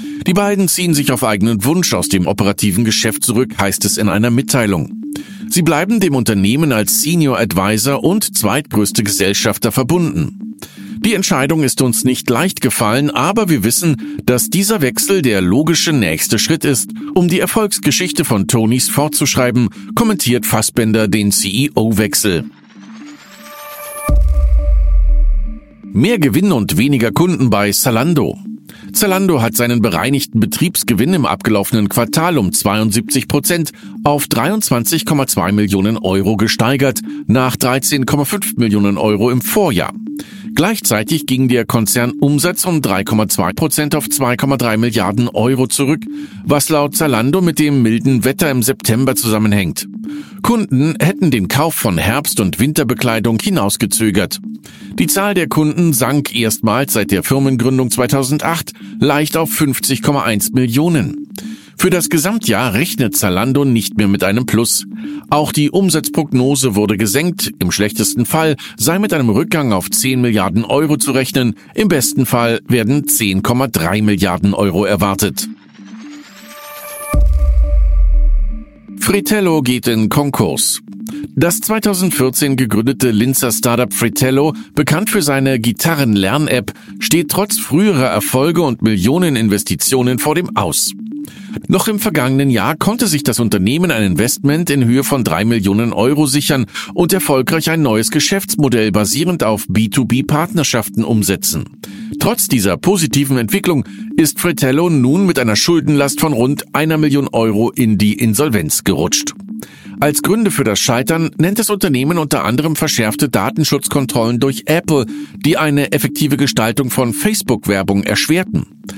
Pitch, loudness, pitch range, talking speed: 135 Hz, -14 LUFS, 110-165 Hz, 130 wpm